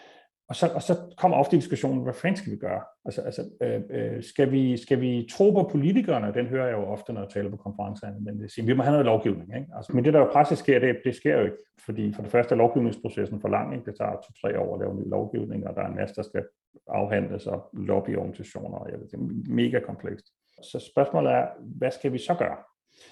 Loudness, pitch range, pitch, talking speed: -26 LUFS, 105-140 Hz, 125 Hz, 245 wpm